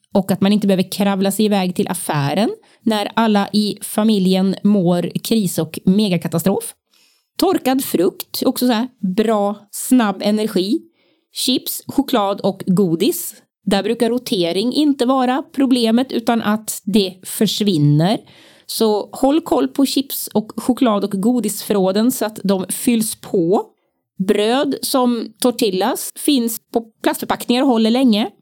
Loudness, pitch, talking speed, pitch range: -17 LUFS, 220 Hz, 135 wpm, 195-250 Hz